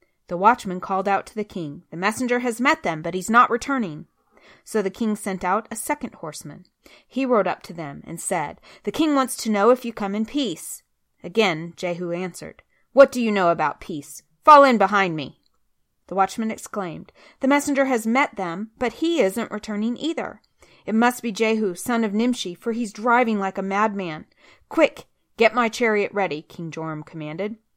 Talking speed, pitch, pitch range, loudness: 190 wpm, 215 Hz, 185-245 Hz, -22 LUFS